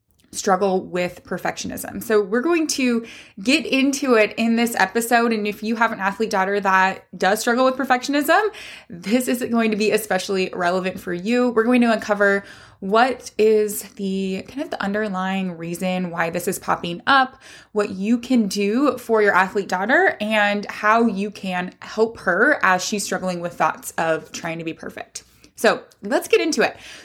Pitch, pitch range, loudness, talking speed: 210 Hz, 190-240 Hz, -20 LUFS, 175 wpm